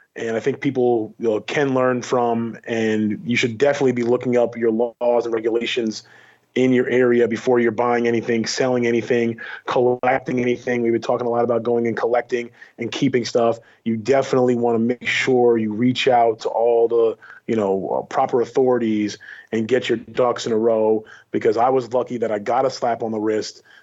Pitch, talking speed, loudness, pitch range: 120 Hz, 195 wpm, -20 LUFS, 115-125 Hz